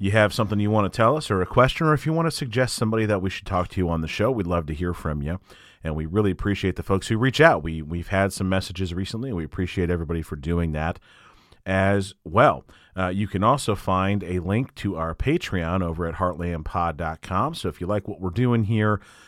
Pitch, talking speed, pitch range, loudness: 95 Hz, 245 wpm, 85-110 Hz, -24 LUFS